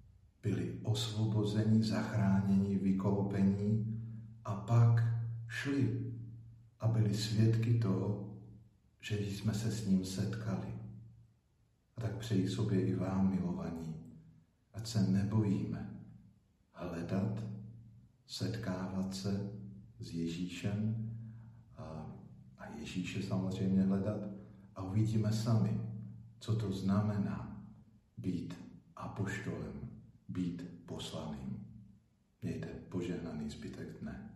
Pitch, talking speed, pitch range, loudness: 105 Hz, 90 wpm, 95-110 Hz, -36 LUFS